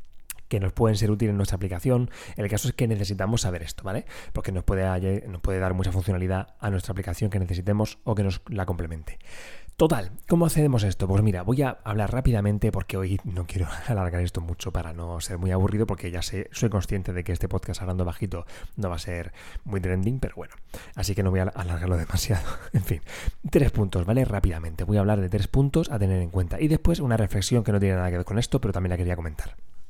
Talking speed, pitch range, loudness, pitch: 235 wpm, 90-110 Hz, -26 LUFS, 95 Hz